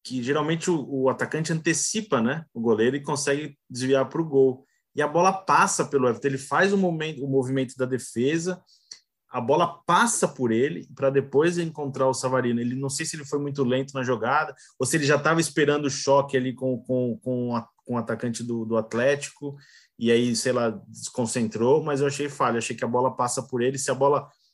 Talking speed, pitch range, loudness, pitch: 215 wpm, 125-150 Hz, -24 LUFS, 135 Hz